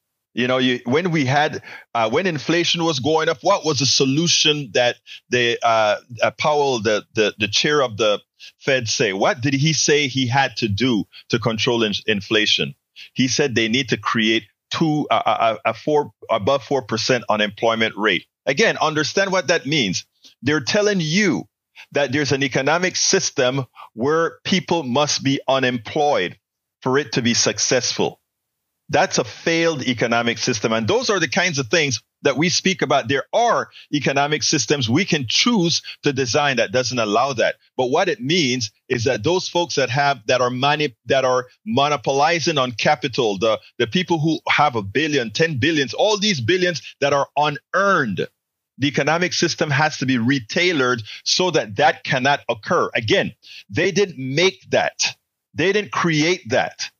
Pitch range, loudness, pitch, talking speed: 125-165 Hz, -19 LUFS, 140 Hz, 175 wpm